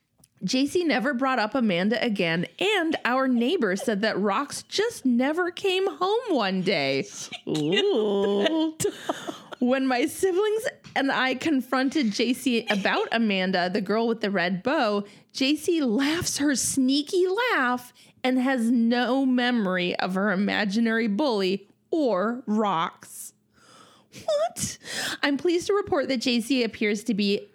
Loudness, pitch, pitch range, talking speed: -25 LUFS, 250 Hz, 210-300 Hz, 130 wpm